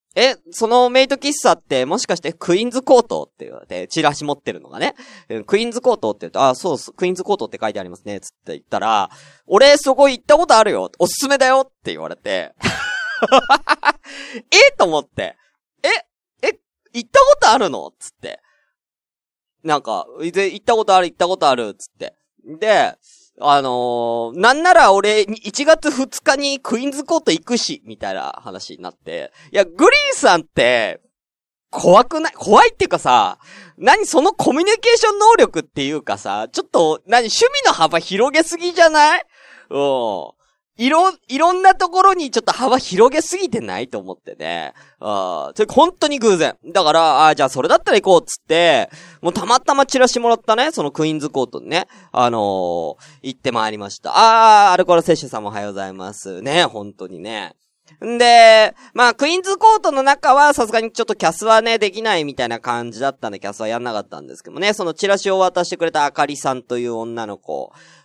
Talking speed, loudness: 390 characters per minute, -15 LUFS